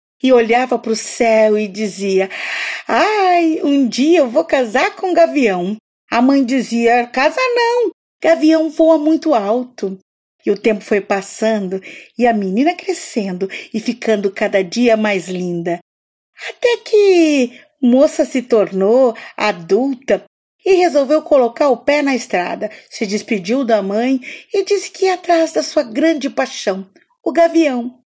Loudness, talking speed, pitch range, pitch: -15 LUFS, 145 wpm, 215-315 Hz, 250 Hz